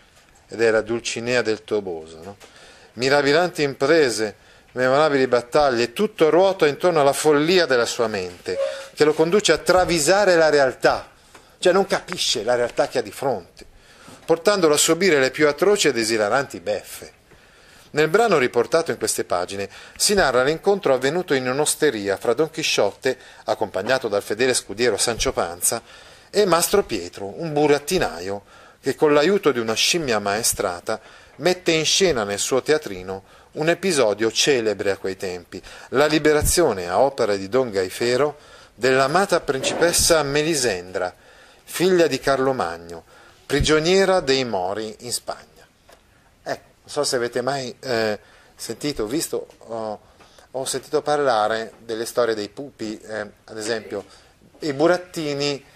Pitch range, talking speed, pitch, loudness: 110-165 Hz, 140 wpm, 140 Hz, -20 LUFS